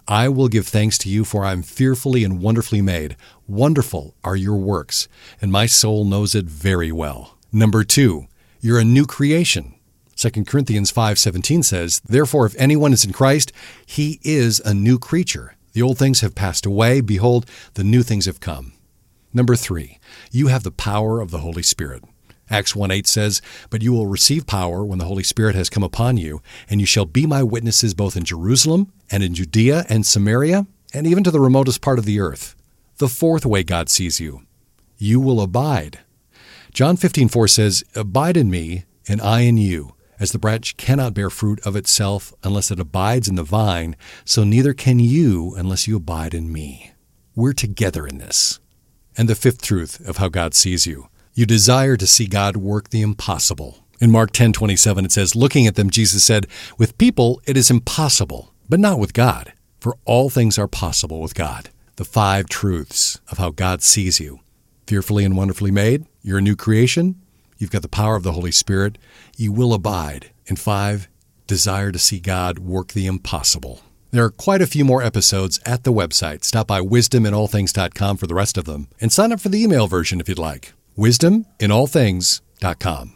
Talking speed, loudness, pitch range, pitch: 190 wpm, -17 LUFS, 95-120 Hz, 105 Hz